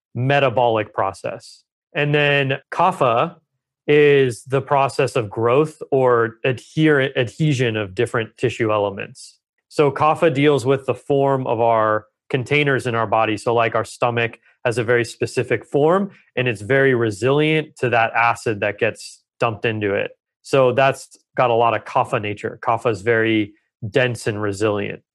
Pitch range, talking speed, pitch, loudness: 115-140 Hz, 155 wpm, 125 Hz, -19 LUFS